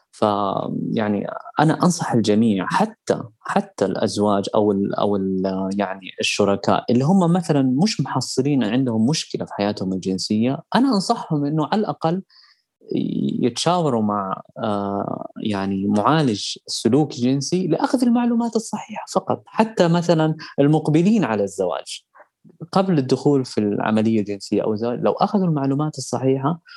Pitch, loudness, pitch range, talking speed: 135 Hz, -20 LUFS, 105-170 Hz, 120 wpm